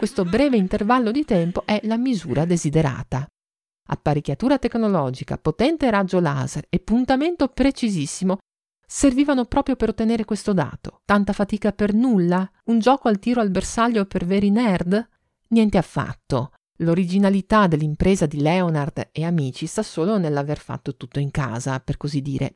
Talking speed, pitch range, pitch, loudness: 145 wpm, 150-225 Hz, 190 Hz, -21 LUFS